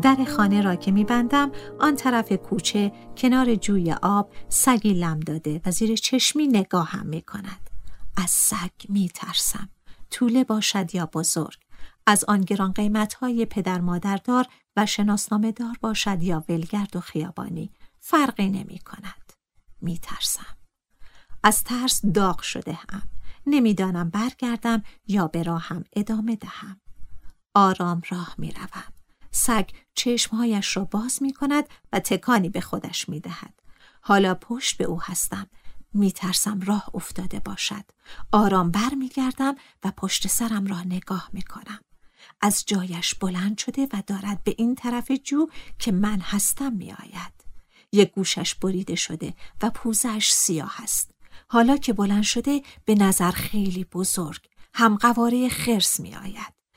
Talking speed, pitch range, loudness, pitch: 135 wpm, 185-235 Hz, -23 LUFS, 205 Hz